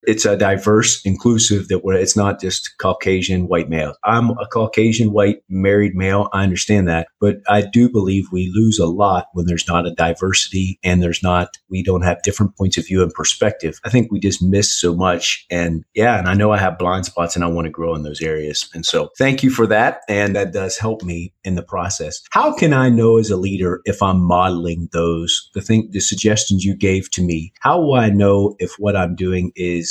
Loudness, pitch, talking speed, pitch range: -17 LUFS, 95 Hz, 225 wpm, 90-105 Hz